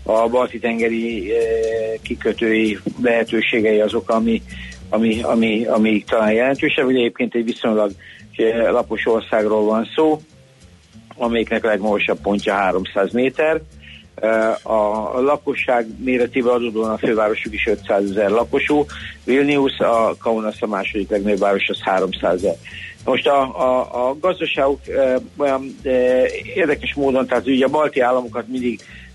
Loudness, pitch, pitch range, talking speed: -18 LUFS, 115 Hz, 110-130 Hz, 125 wpm